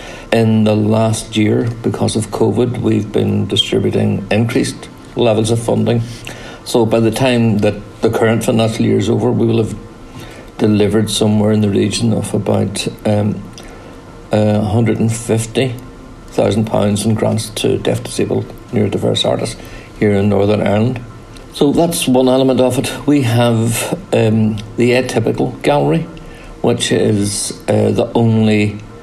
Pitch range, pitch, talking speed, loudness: 105-120 Hz, 115 Hz, 135 wpm, -14 LUFS